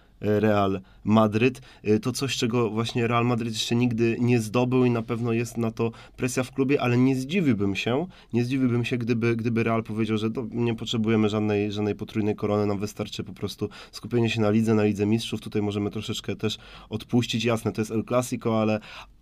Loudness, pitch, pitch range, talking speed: -25 LUFS, 115 Hz, 105-120 Hz, 190 wpm